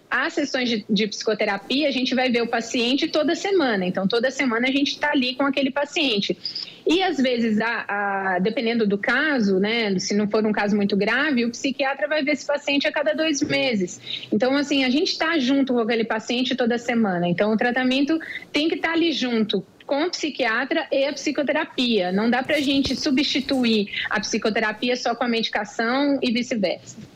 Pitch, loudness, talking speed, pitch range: 255 Hz, -22 LUFS, 195 wpm, 225-290 Hz